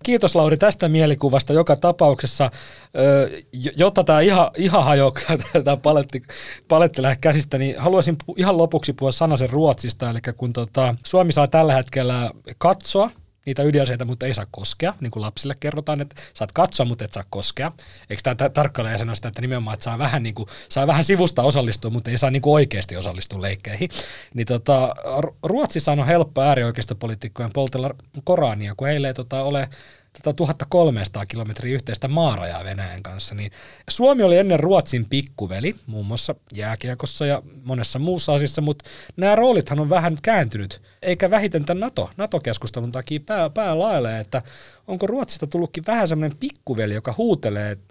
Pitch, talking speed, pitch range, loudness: 140 Hz, 160 wpm, 120-160 Hz, -20 LUFS